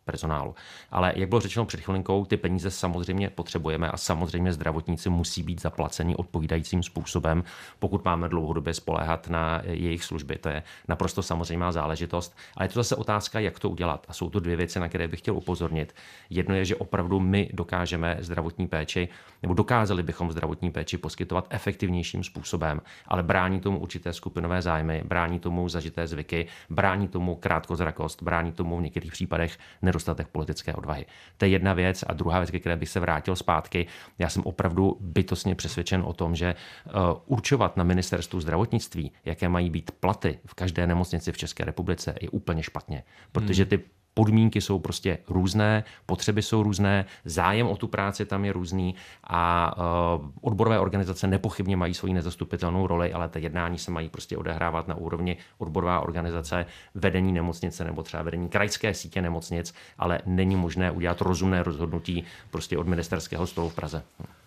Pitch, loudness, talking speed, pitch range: 90 Hz, -28 LUFS, 170 wpm, 85-95 Hz